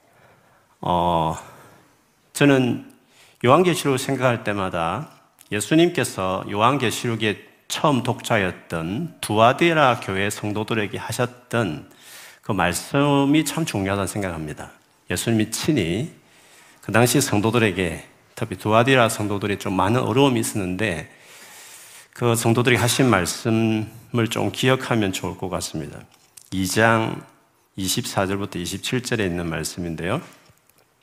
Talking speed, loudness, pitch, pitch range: 255 characters per minute, -21 LUFS, 110 Hz, 95-125 Hz